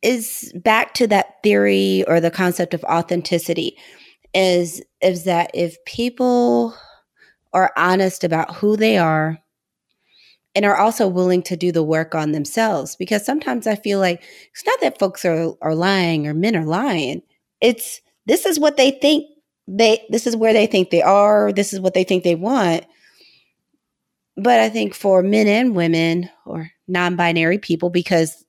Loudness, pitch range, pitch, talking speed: -18 LUFS, 170-220 Hz, 185 Hz, 165 wpm